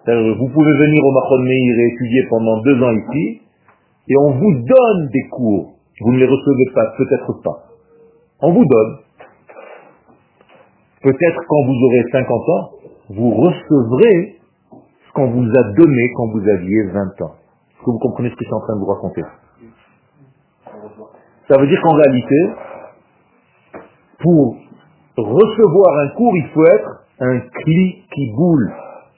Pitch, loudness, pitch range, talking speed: 135 Hz, -14 LUFS, 120-155 Hz, 155 wpm